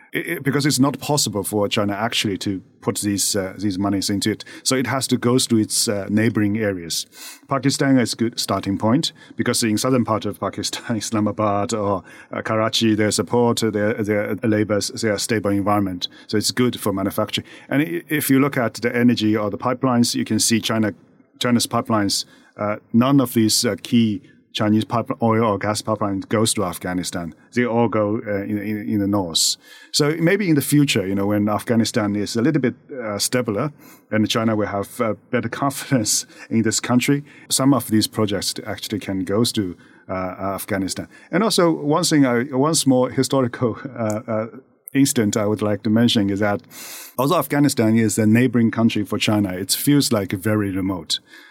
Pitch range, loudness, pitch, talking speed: 105-125 Hz, -20 LUFS, 110 Hz, 185 wpm